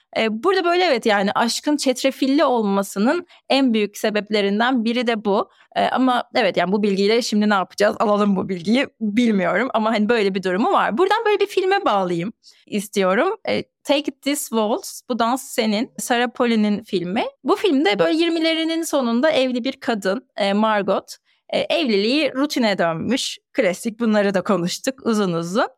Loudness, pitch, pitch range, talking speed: -20 LUFS, 235 Hz, 205-280 Hz, 150 wpm